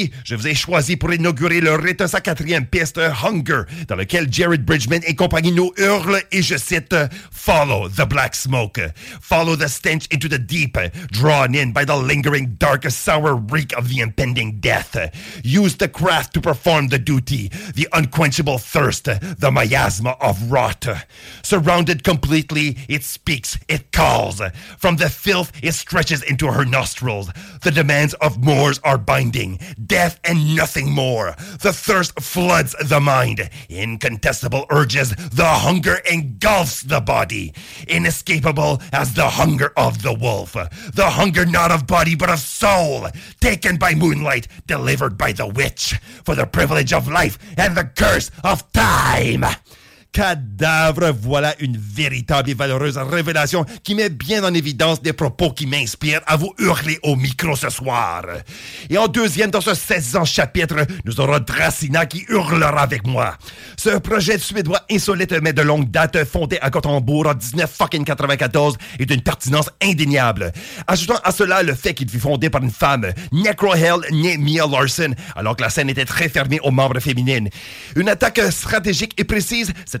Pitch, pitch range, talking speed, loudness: 150 Hz, 135-170 Hz, 160 wpm, -17 LUFS